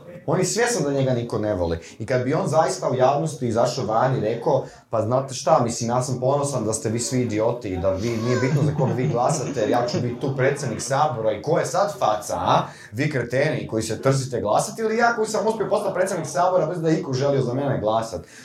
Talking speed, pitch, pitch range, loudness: 235 wpm, 130 Hz, 115-160 Hz, -22 LUFS